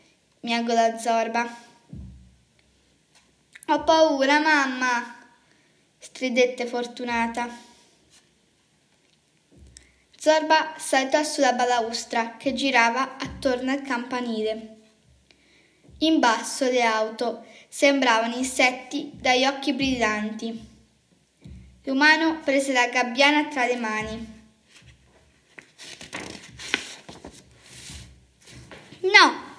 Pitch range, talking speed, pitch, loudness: 225-275 Hz, 65 wpm, 240 Hz, -22 LUFS